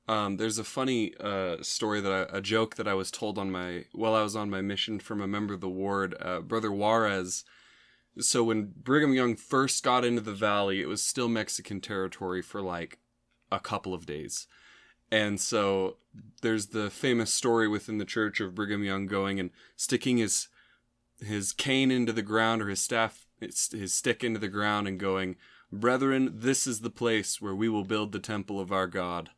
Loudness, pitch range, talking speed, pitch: -29 LUFS, 95-115 Hz, 195 wpm, 105 Hz